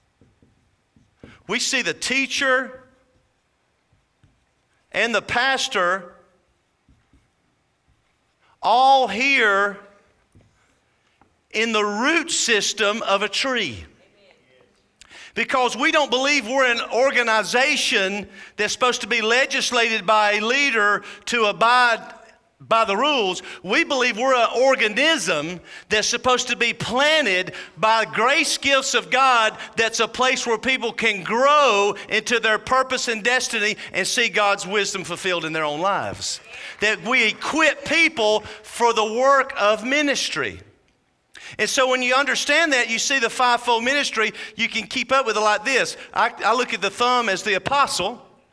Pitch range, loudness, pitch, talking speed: 210-260 Hz, -19 LUFS, 235 Hz, 135 wpm